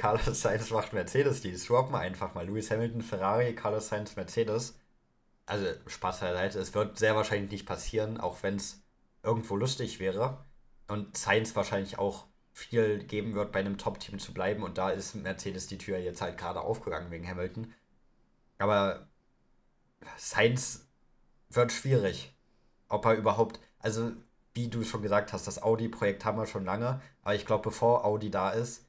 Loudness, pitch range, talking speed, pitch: -32 LUFS, 95-115 Hz, 165 wpm, 105 Hz